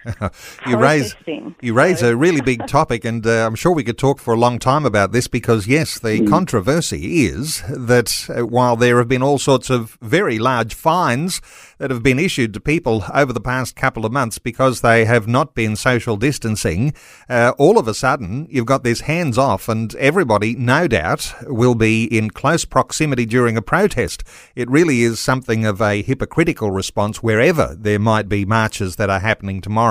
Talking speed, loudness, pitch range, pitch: 190 wpm, -17 LUFS, 110-135 Hz, 120 Hz